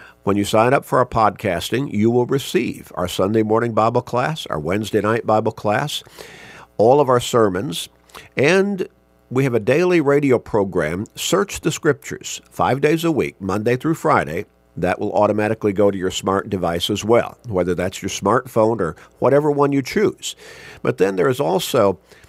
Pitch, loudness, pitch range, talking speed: 110 Hz, -19 LUFS, 100-135 Hz, 175 wpm